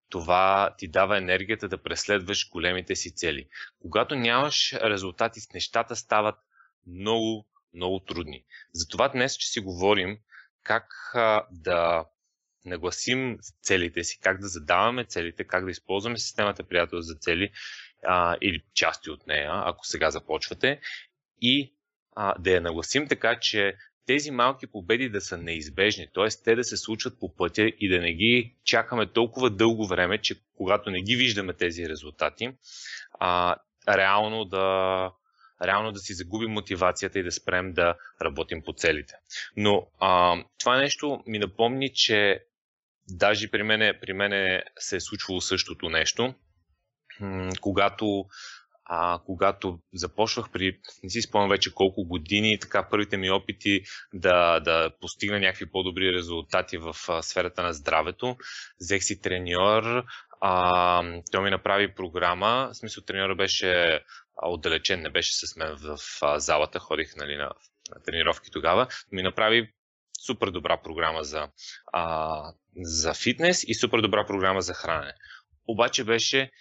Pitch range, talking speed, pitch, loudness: 90-110 Hz, 140 wpm, 95 Hz, -26 LUFS